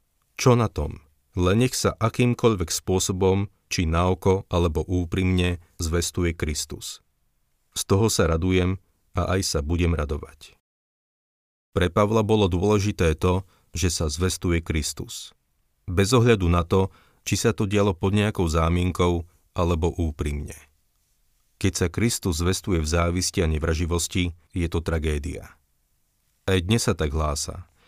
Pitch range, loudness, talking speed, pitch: 80-100 Hz, -24 LUFS, 130 wpm, 90 Hz